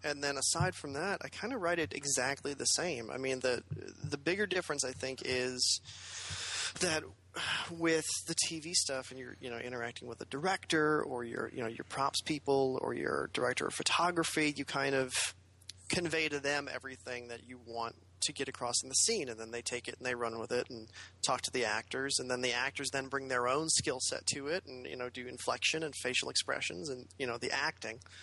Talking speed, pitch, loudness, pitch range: 220 wpm, 130 Hz, -34 LUFS, 120-145 Hz